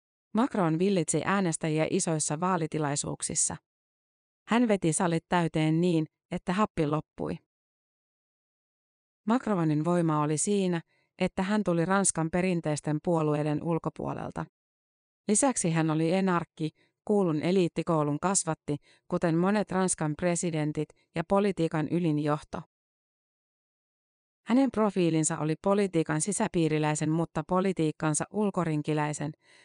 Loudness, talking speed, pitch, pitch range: -28 LUFS, 95 wpm, 165 Hz, 155-185 Hz